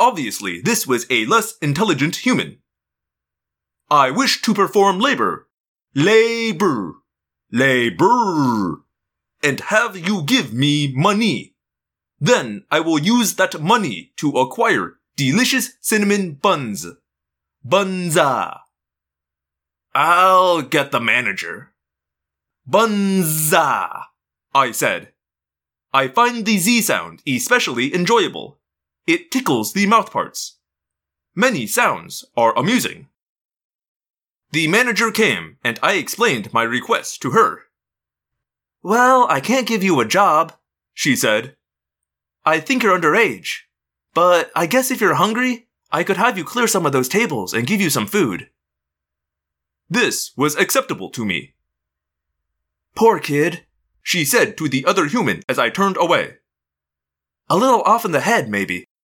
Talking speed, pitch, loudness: 125 wpm, 150 Hz, -17 LUFS